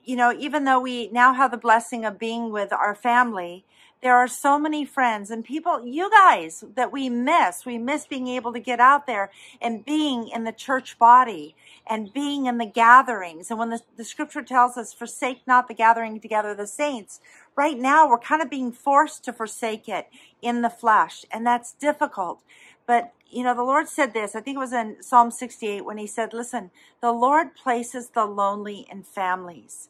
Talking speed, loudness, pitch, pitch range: 205 wpm, -22 LUFS, 240 Hz, 225-265 Hz